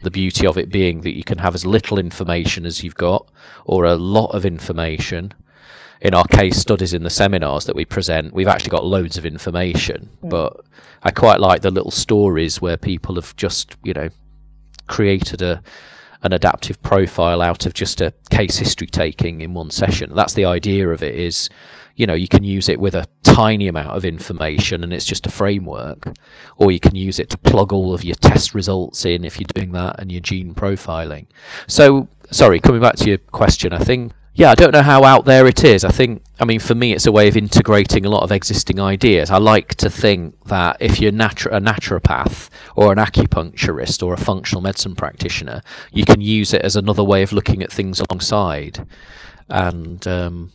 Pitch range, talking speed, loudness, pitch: 85-105 Hz, 205 wpm, -16 LUFS, 95 Hz